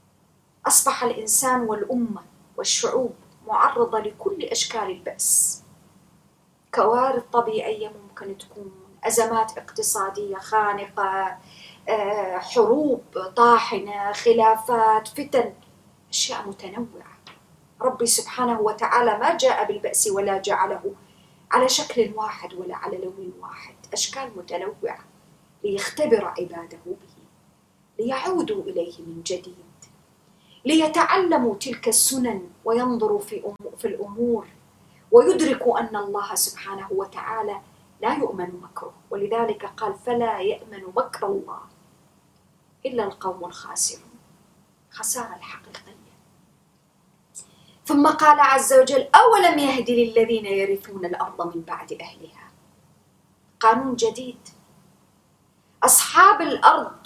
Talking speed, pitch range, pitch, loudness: 90 wpm, 195-265 Hz, 225 Hz, -21 LUFS